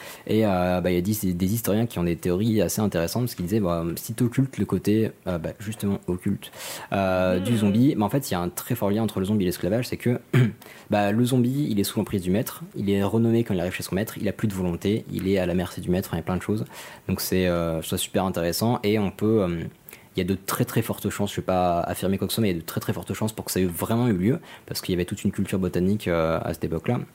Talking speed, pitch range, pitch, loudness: 305 wpm, 90-110 Hz, 100 Hz, -25 LUFS